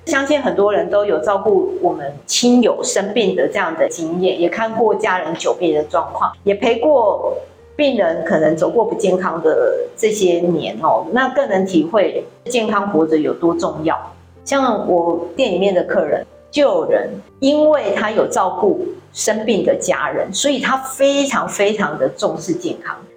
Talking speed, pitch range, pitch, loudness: 245 characters per minute, 190-320 Hz, 245 Hz, -17 LUFS